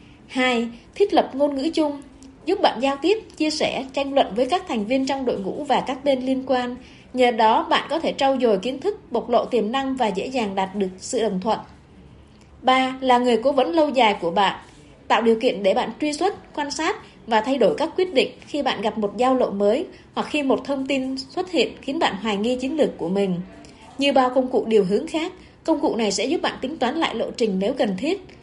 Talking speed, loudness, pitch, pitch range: 240 wpm, -22 LUFS, 260 Hz, 225-290 Hz